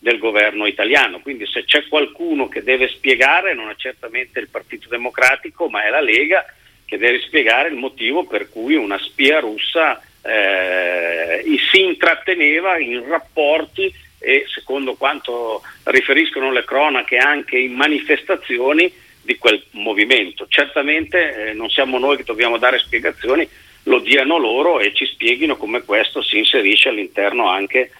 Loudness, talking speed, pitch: -15 LUFS, 145 wpm, 160 Hz